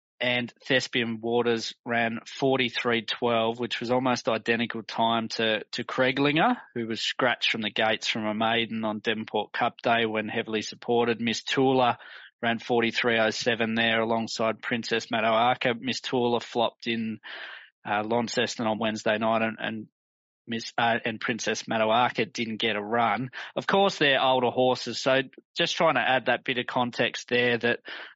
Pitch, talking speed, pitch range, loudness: 115 Hz, 155 wpm, 110-125 Hz, -26 LUFS